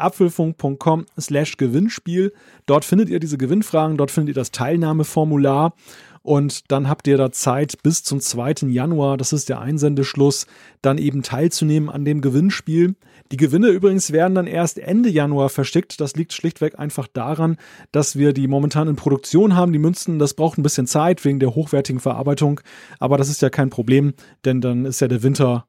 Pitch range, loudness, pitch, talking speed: 140-165 Hz, -19 LUFS, 150 Hz, 180 wpm